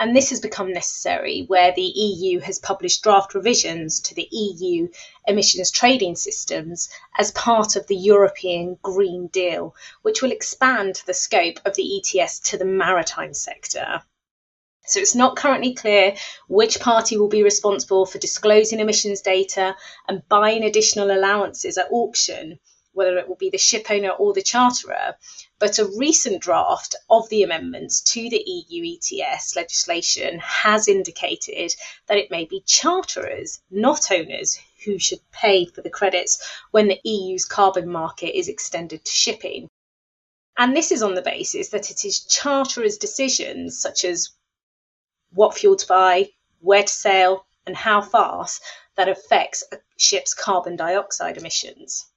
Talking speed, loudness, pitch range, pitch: 155 wpm, -19 LUFS, 190-270 Hz, 205 Hz